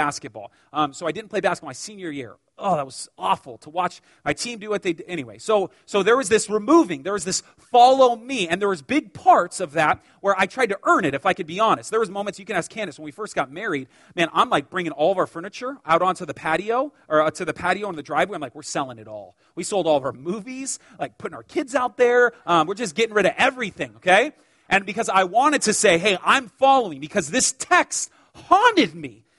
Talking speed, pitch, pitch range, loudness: 250 wpm, 205 Hz, 170-245 Hz, -21 LUFS